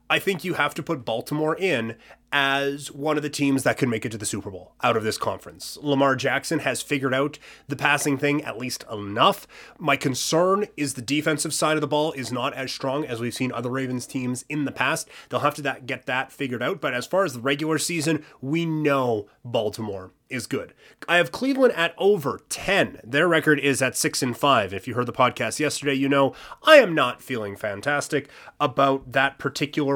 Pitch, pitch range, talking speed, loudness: 140 Hz, 130-150 Hz, 215 wpm, -23 LUFS